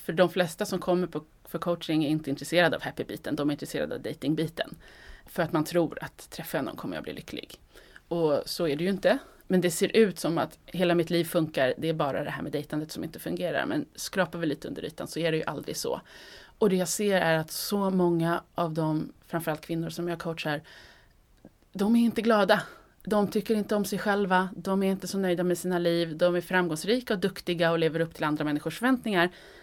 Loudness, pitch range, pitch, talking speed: -28 LUFS, 160-195 Hz, 175 Hz, 225 wpm